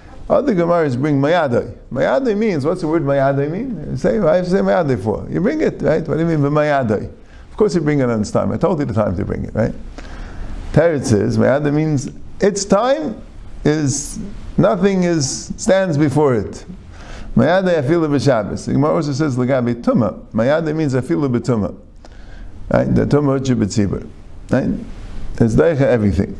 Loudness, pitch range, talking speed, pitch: -17 LUFS, 130-170 Hz, 175 wpm, 150 Hz